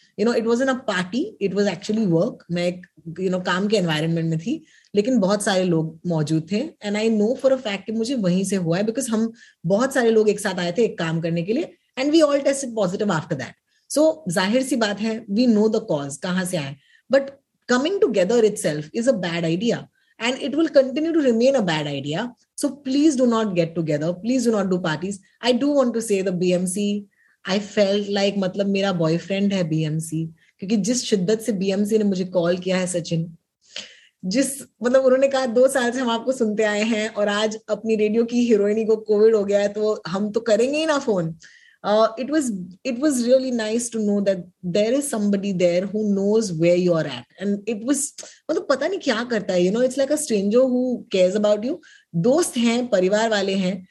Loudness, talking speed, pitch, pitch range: -21 LUFS, 180 wpm, 210 Hz, 185-245 Hz